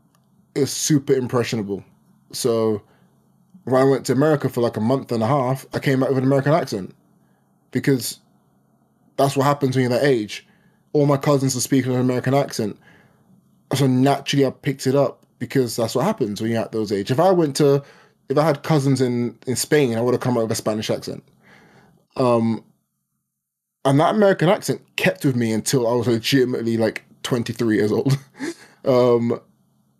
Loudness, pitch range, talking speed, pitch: -20 LUFS, 115-140 Hz, 180 wpm, 130 Hz